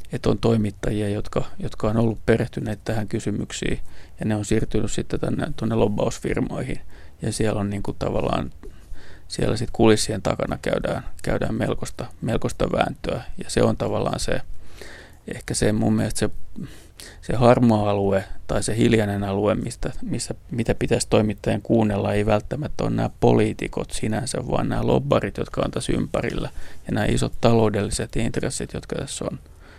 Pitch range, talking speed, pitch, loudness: 100-115 Hz, 155 wpm, 105 Hz, -23 LUFS